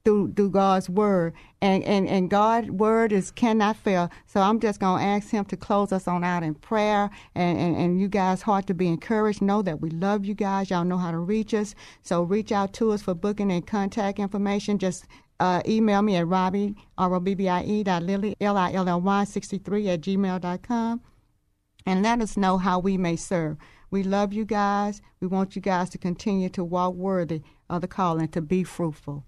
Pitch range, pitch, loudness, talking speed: 180-205 Hz, 195 Hz, -25 LUFS, 220 wpm